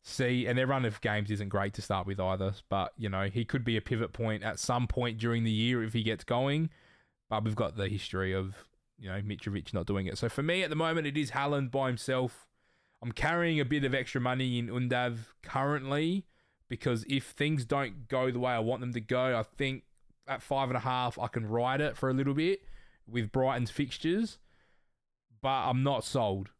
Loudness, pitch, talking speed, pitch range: -32 LUFS, 125 Hz, 220 wpm, 110-135 Hz